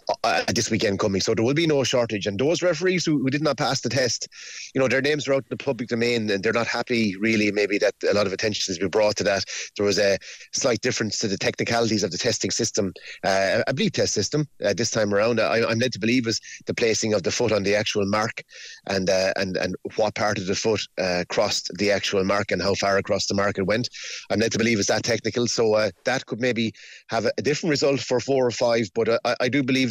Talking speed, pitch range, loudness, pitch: 265 wpm, 105-130 Hz, -23 LUFS, 115 Hz